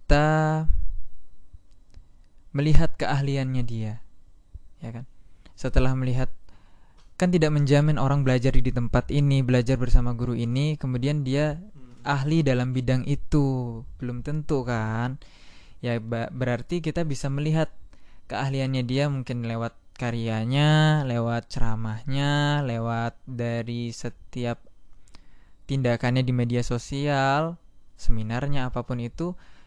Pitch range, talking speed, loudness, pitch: 115-140 Hz, 105 wpm, -26 LUFS, 125 Hz